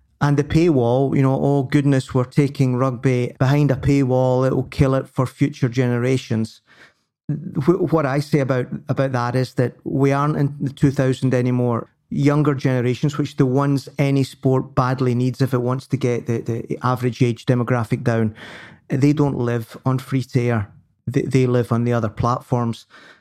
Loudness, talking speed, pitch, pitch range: -20 LUFS, 175 wpm, 130 Hz, 125-140 Hz